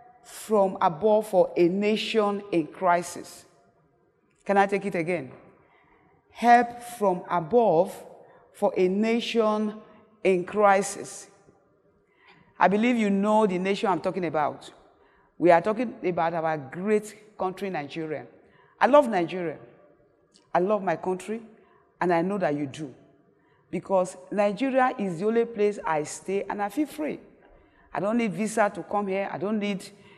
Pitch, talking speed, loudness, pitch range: 200 Hz, 145 wpm, -25 LUFS, 175-215 Hz